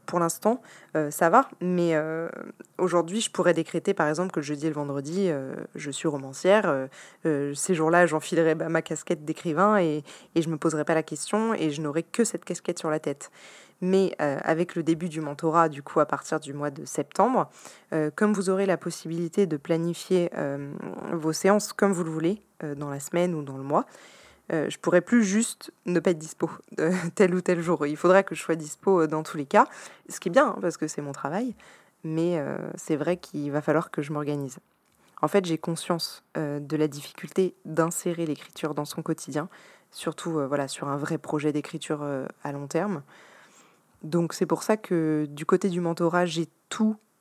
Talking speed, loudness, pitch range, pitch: 210 wpm, -27 LUFS, 155-180 Hz, 165 Hz